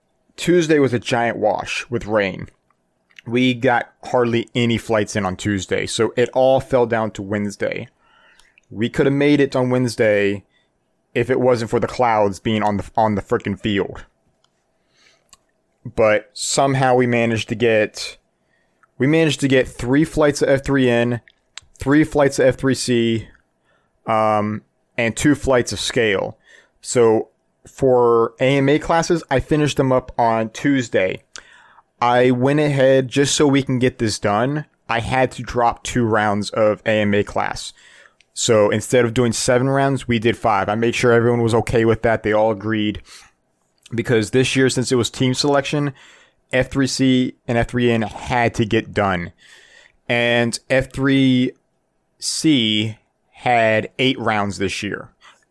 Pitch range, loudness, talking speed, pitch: 110-130 Hz, -18 LUFS, 150 wpm, 120 Hz